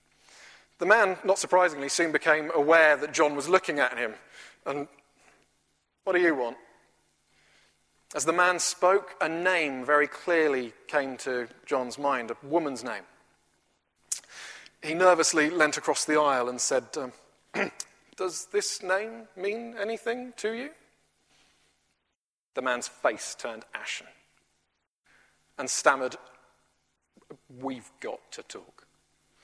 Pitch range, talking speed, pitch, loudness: 130-180 Hz, 120 wpm, 155 Hz, -27 LUFS